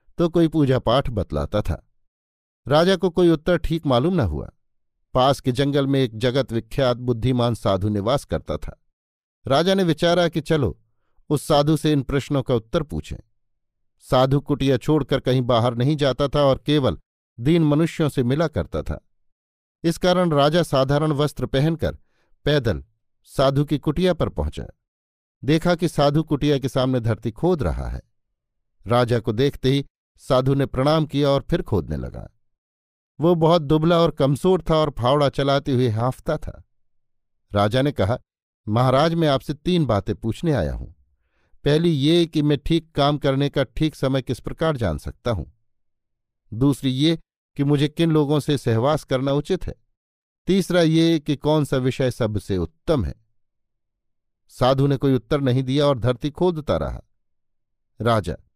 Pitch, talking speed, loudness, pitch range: 130 Hz, 160 wpm, -21 LUFS, 110-150 Hz